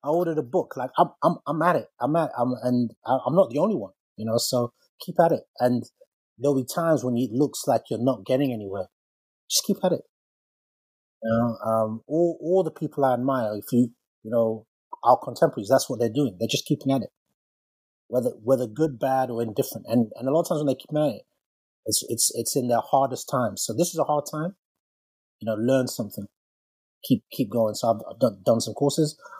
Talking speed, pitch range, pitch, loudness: 220 wpm, 115-145 Hz, 125 Hz, -25 LUFS